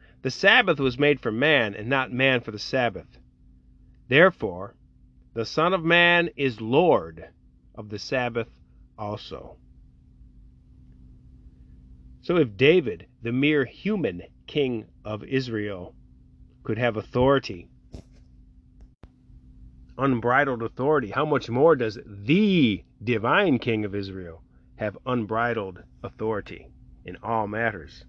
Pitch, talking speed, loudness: 105 Hz, 110 wpm, -23 LUFS